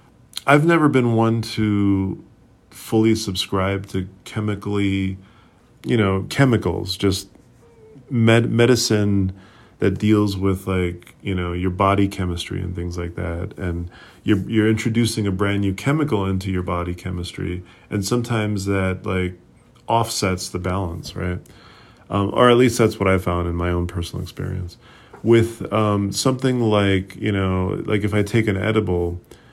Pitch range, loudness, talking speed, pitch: 95-110 Hz, -20 LUFS, 150 wpm, 100 Hz